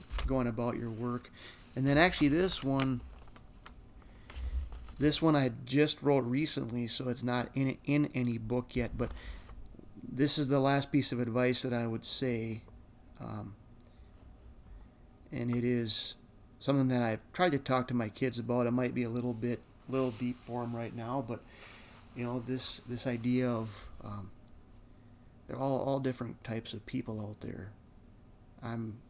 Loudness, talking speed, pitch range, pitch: -33 LUFS, 165 wpm, 110-130 Hz, 120 Hz